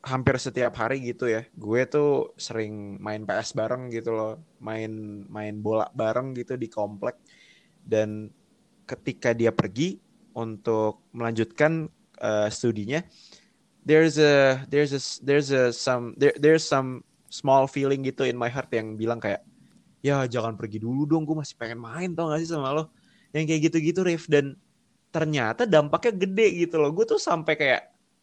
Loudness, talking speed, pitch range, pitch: -25 LUFS, 160 wpm, 115-155 Hz, 130 Hz